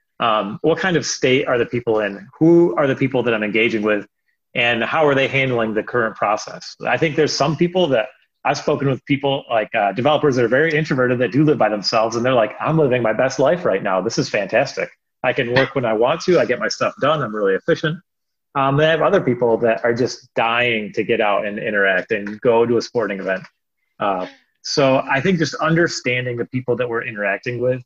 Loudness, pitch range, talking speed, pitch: -18 LUFS, 115-150 Hz, 245 wpm, 130 Hz